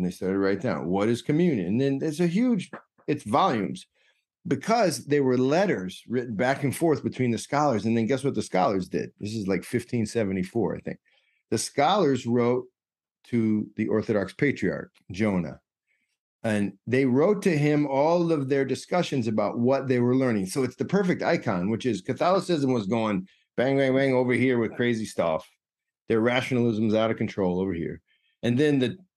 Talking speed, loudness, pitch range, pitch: 185 wpm, -25 LUFS, 110-140 Hz, 125 Hz